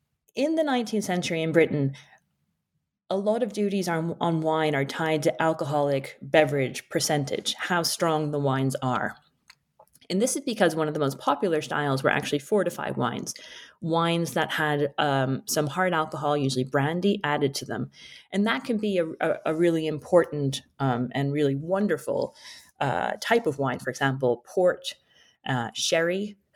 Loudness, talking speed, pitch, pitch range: -26 LUFS, 165 wpm, 160 Hz, 140-185 Hz